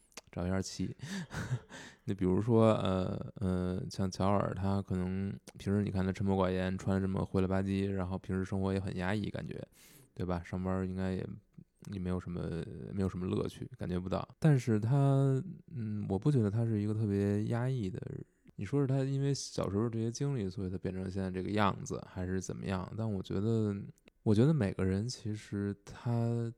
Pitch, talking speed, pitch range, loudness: 100 Hz, 290 characters per minute, 95-115 Hz, -34 LUFS